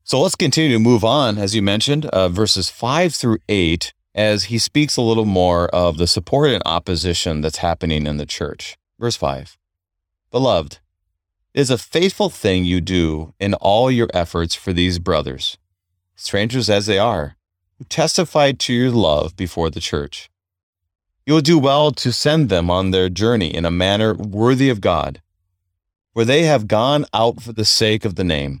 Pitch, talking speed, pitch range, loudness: 95 Hz, 180 wpm, 85-115 Hz, -17 LUFS